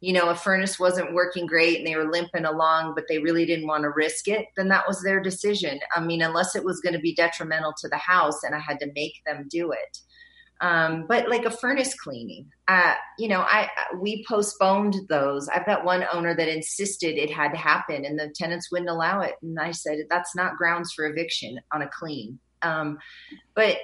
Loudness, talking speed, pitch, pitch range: -24 LUFS, 220 wpm, 170 Hz, 160-190 Hz